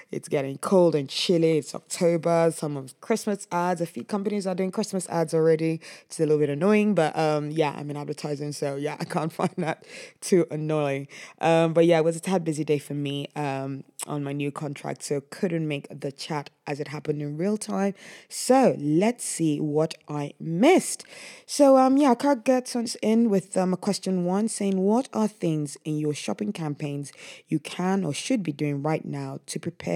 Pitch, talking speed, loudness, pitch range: 165 Hz, 200 wpm, -25 LUFS, 150-195 Hz